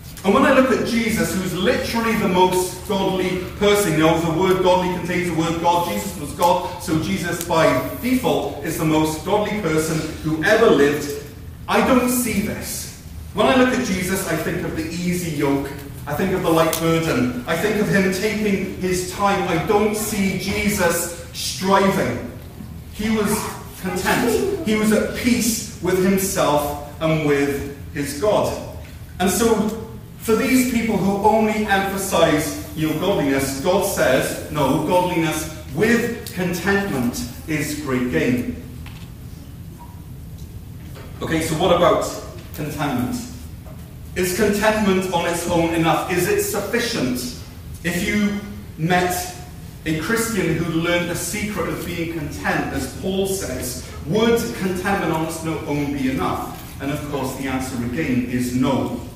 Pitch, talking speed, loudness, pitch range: 180 Hz, 145 wpm, -20 LUFS, 155-205 Hz